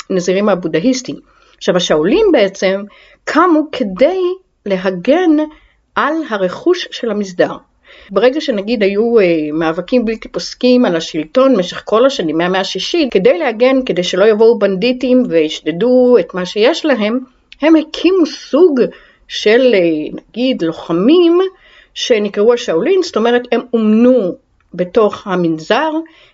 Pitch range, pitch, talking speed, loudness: 190-300 Hz, 240 Hz, 115 wpm, -13 LUFS